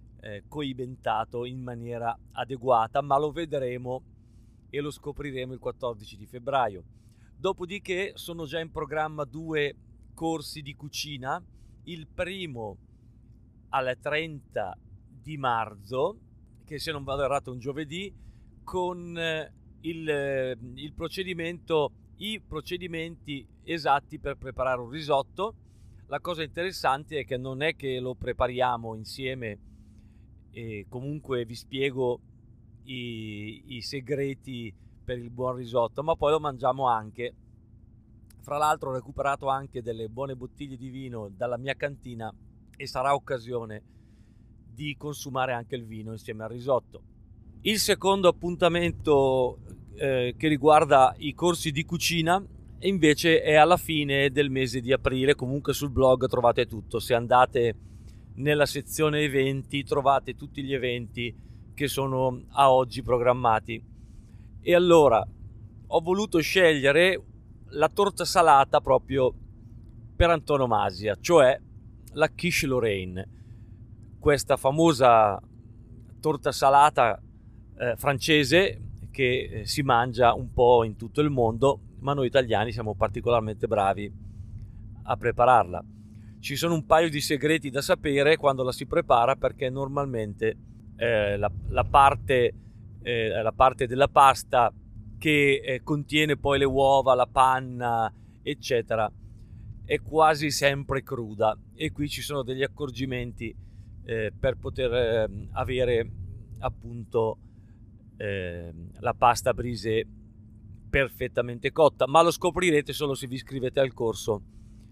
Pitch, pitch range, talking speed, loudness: 125 Hz, 110-145 Hz, 125 wpm, -25 LUFS